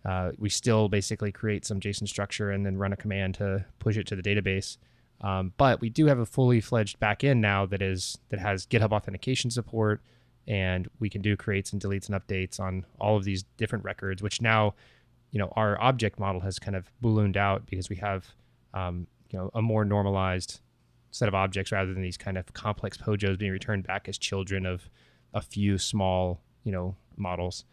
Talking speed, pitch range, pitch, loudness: 205 wpm, 95-110 Hz, 100 Hz, -29 LUFS